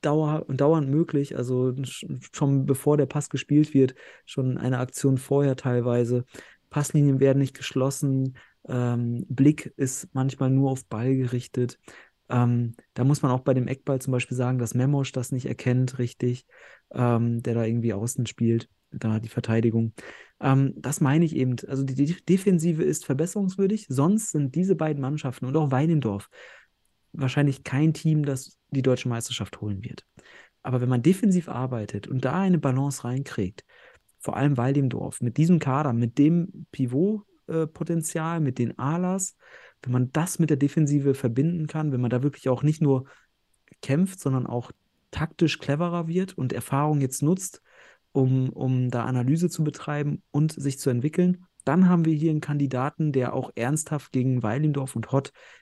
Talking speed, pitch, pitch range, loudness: 160 wpm, 135 Hz, 125-155 Hz, -25 LUFS